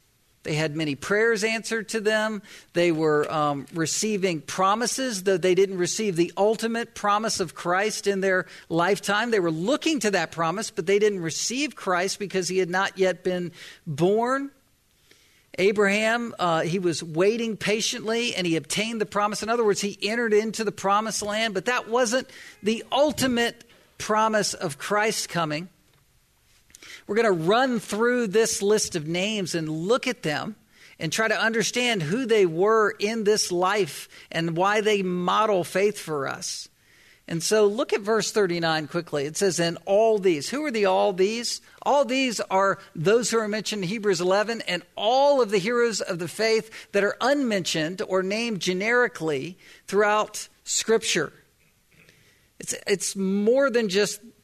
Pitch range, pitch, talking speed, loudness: 180-225 Hz, 205 Hz, 165 wpm, -24 LUFS